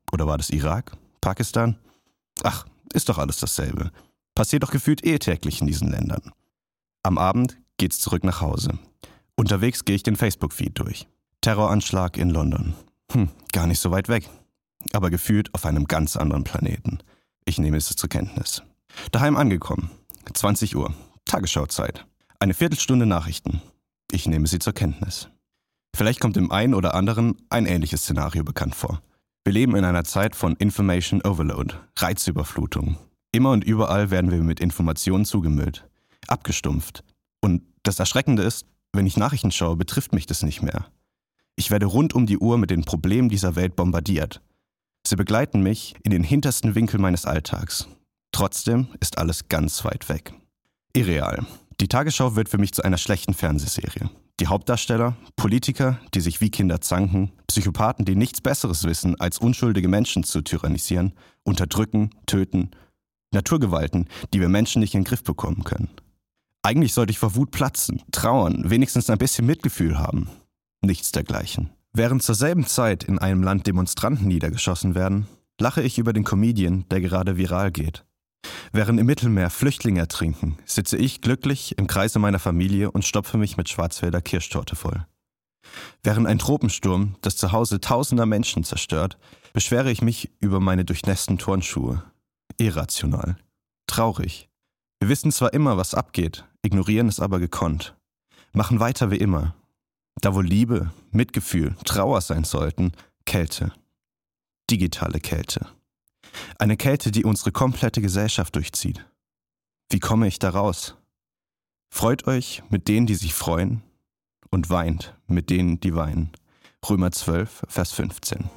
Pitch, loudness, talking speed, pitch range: 100 Hz, -23 LUFS, 150 wpm, 90-115 Hz